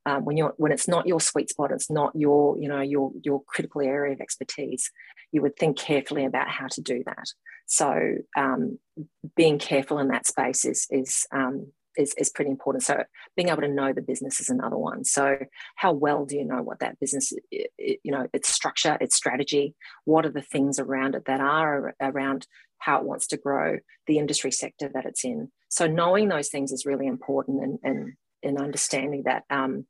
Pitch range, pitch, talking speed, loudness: 135-155 Hz, 145 Hz, 205 wpm, -26 LUFS